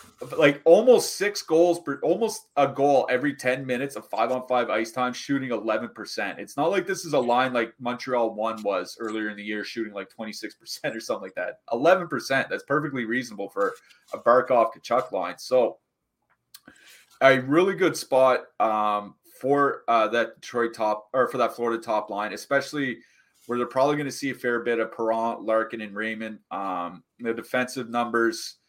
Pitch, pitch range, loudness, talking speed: 120 Hz, 110-135 Hz, -25 LUFS, 180 wpm